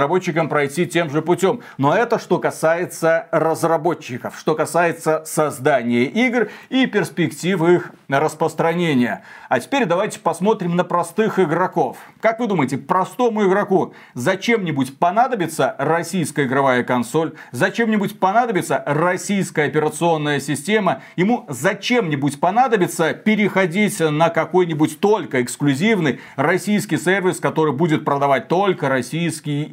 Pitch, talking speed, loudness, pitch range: 170 Hz, 110 wpm, -19 LUFS, 155-190 Hz